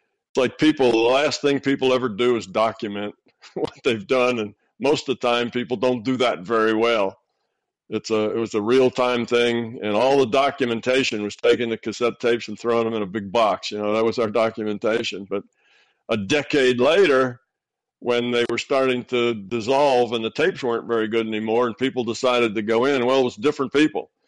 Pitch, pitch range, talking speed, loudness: 120 Hz, 110-125 Hz, 205 wpm, -21 LUFS